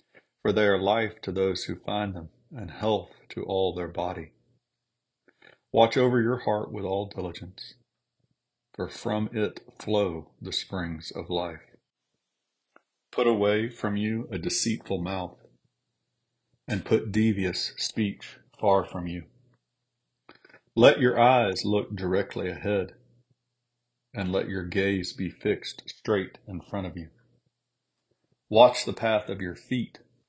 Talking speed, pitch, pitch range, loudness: 135 wpm, 100 Hz, 90-120 Hz, -27 LUFS